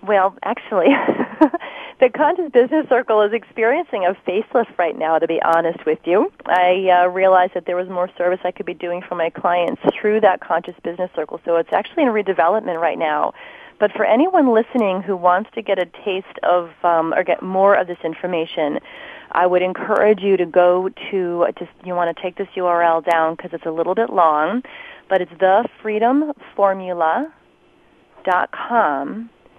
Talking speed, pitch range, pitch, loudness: 175 wpm, 175-220 Hz, 185 Hz, -18 LUFS